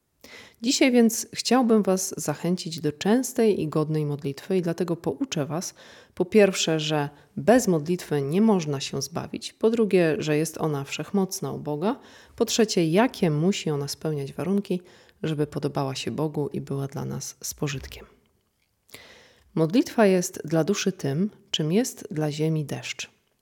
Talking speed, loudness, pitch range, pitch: 145 wpm, -25 LUFS, 150-205 Hz, 170 Hz